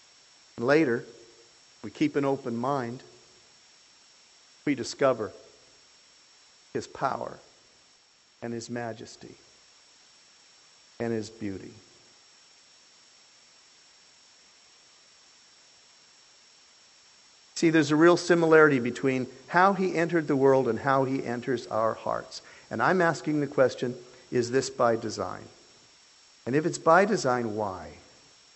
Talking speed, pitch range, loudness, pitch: 100 wpm, 115-155 Hz, -26 LUFS, 130 Hz